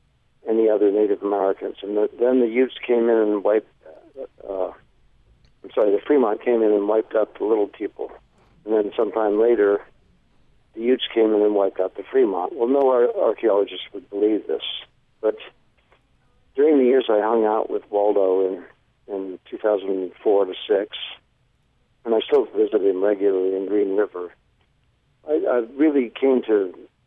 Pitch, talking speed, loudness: 115 Hz, 165 wpm, -21 LUFS